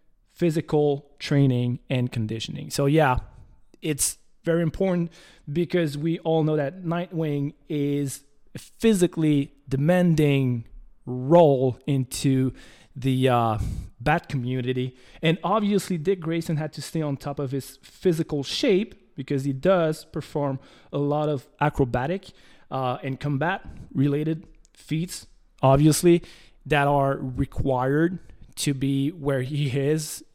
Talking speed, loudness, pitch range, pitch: 115 wpm, -24 LUFS, 135-165 Hz, 145 Hz